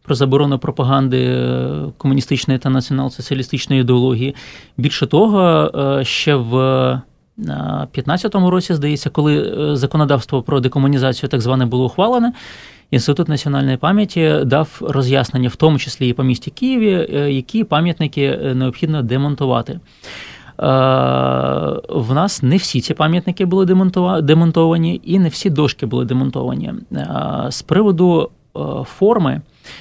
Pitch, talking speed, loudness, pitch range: 140 Hz, 110 wpm, -16 LUFS, 130-165 Hz